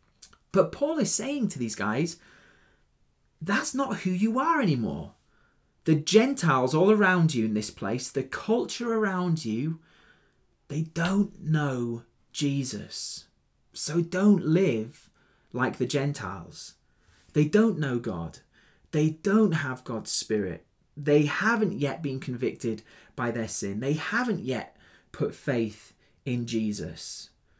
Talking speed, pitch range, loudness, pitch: 130 wpm, 115-190 Hz, -27 LUFS, 145 Hz